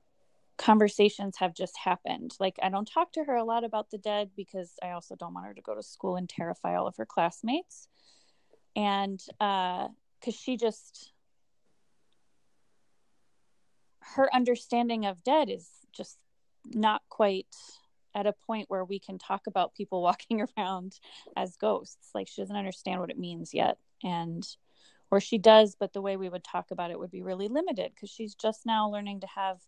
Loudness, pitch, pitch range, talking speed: -30 LUFS, 205 Hz, 185-225 Hz, 180 wpm